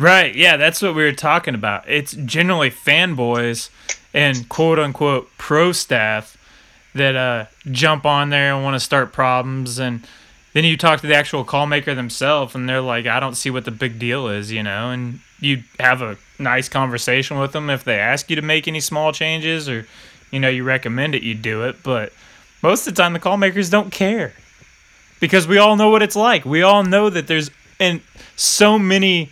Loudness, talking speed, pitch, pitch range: -17 LUFS, 200 wpm, 145 Hz, 125-160 Hz